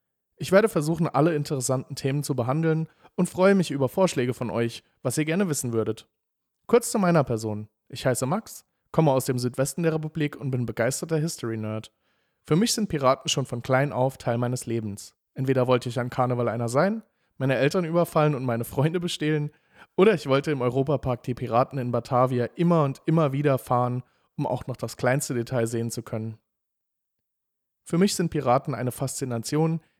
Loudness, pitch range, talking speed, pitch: -25 LUFS, 120-160 Hz, 180 wpm, 135 Hz